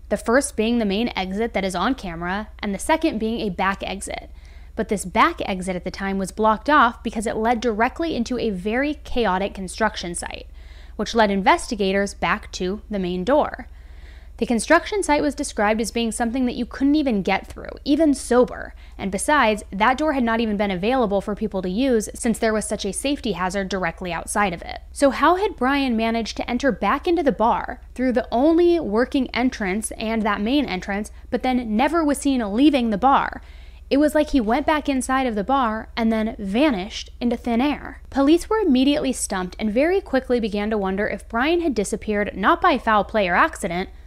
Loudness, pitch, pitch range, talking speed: -21 LUFS, 230 Hz, 210-275 Hz, 205 wpm